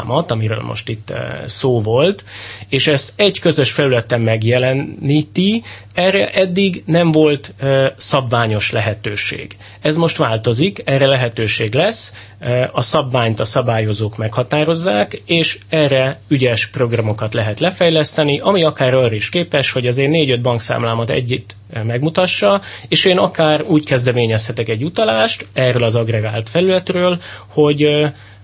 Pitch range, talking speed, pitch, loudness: 110-155 Hz, 135 wpm, 130 Hz, -15 LUFS